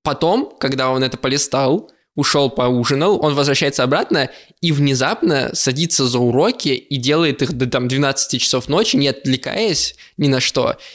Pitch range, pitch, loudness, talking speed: 130-145 Hz, 135 Hz, -17 LUFS, 155 wpm